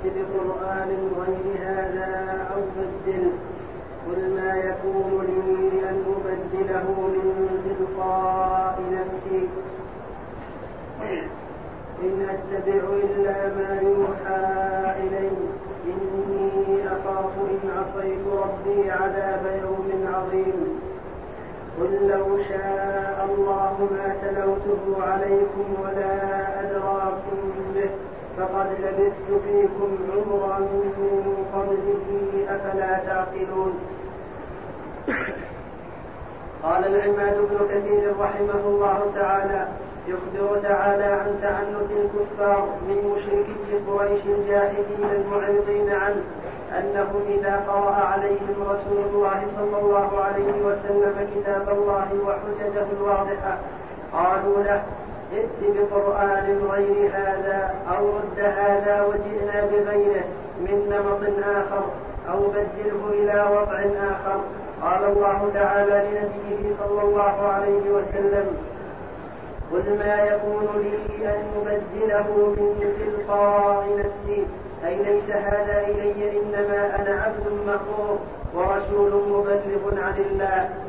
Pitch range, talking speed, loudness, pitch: 195-205 Hz, 90 wpm, -23 LUFS, 200 Hz